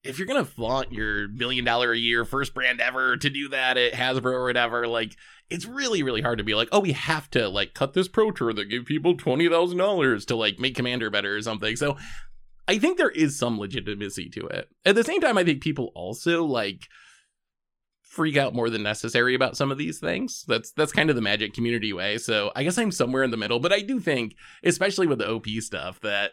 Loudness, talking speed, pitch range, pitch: -24 LUFS, 230 wpm, 115-155 Hz, 125 Hz